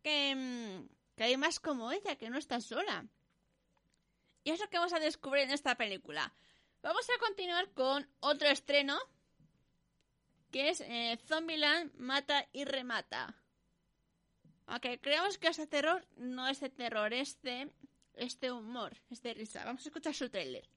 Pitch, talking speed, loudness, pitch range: 280 Hz, 160 wpm, -36 LUFS, 245-310 Hz